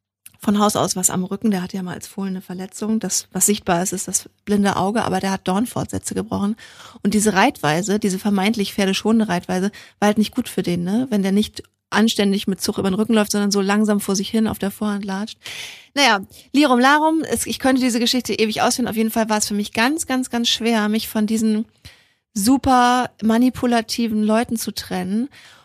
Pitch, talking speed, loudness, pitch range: 210 Hz, 205 wpm, -19 LUFS, 195-230 Hz